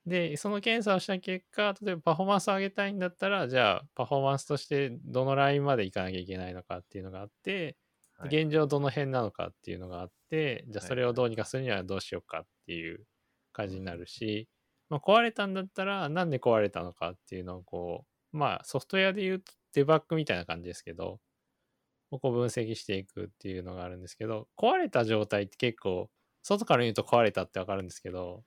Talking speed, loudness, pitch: 455 characters per minute, -31 LUFS, 125 Hz